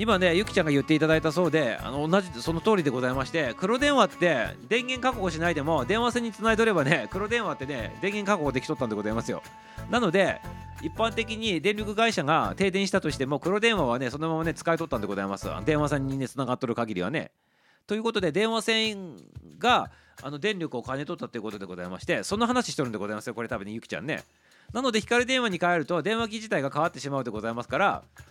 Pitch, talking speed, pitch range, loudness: 170 Hz, 485 characters per minute, 135-215 Hz, -27 LUFS